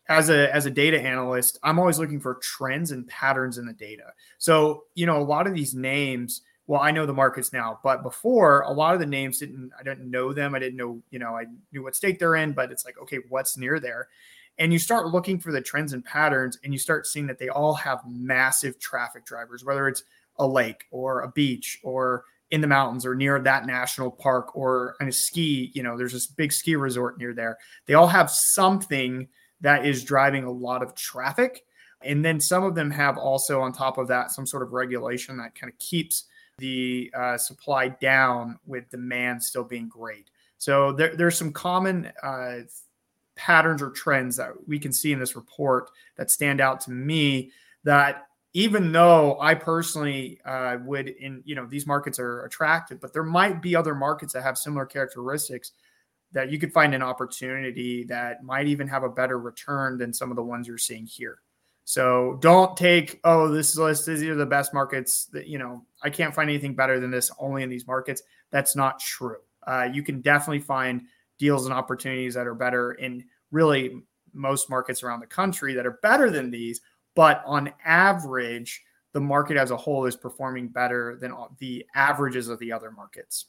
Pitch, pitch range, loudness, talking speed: 135 Hz, 125-150 Hz, -24 LUFS, 205 wpm